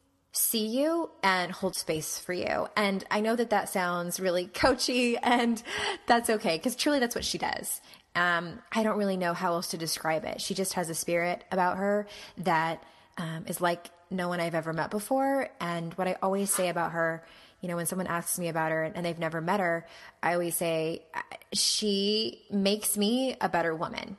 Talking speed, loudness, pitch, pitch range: 200 wpm, -29 LUFS, 180 Hz, 170-210 Hz